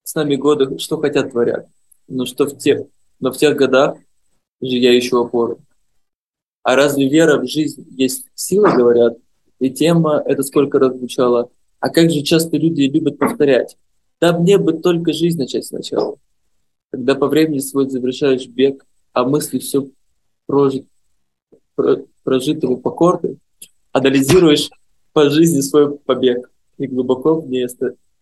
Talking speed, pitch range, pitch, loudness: 140 wpm, 130-155 Hz, 140 Hz, -16 LUFS